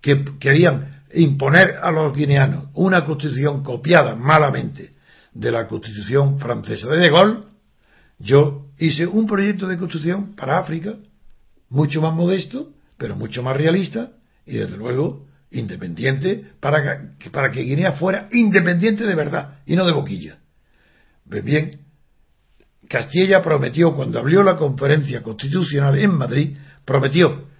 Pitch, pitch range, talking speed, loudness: 155 Hz, 140-180 Hz, 135 wpm, -18 LUFS